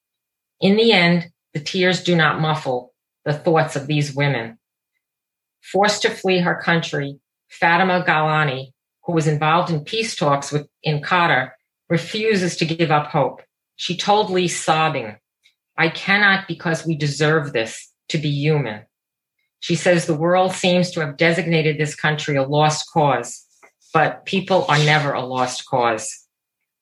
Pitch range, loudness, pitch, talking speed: 145-175 Hz, -19 LUFS, 160 Hz, 150 wpm